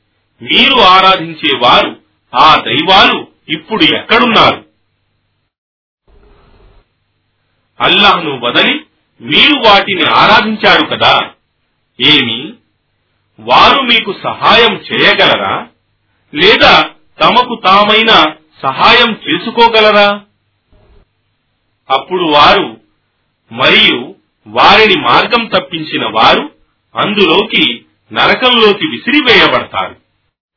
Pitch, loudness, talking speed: 160 Hz, -7 LUFS, 65 wpm